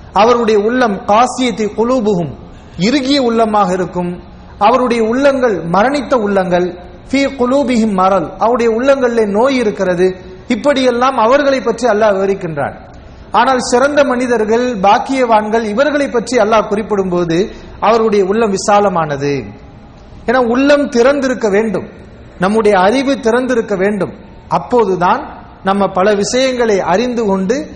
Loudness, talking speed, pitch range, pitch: -13 LUFS, 95 wpm, 190-250 Hz, 220 Hz